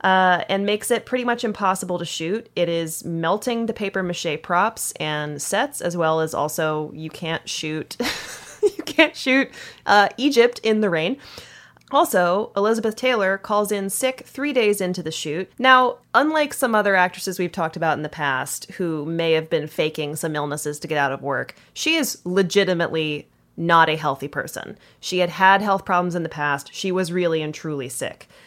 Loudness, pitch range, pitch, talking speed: -21 LUFS, 160-215 Hz, 180 Hz, 185 wpm